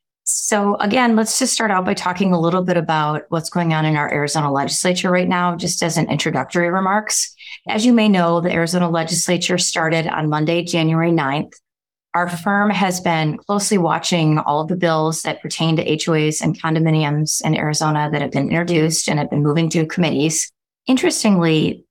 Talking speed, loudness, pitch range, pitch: 185 wpm, -17 LUFS, 155-185 Hz, 170 Hz